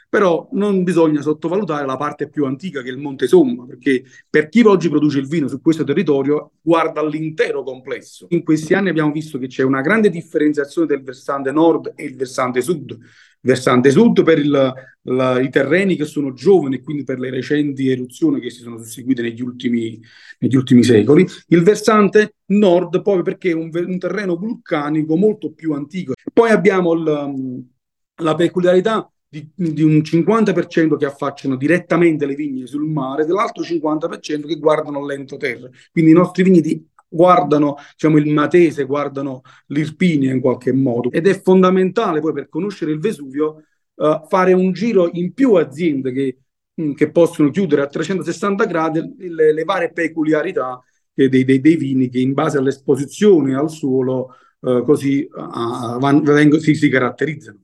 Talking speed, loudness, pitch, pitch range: 165 wpm, -16 LUFS, 150 Hz, 135-175 Hz